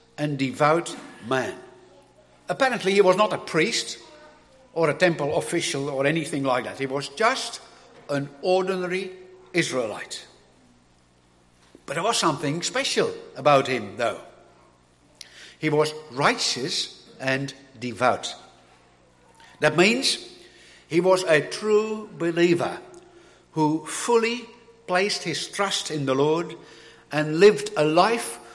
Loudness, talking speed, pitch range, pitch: -23 LUFS, 115 wpm, 135-200 Hz, 160 Hz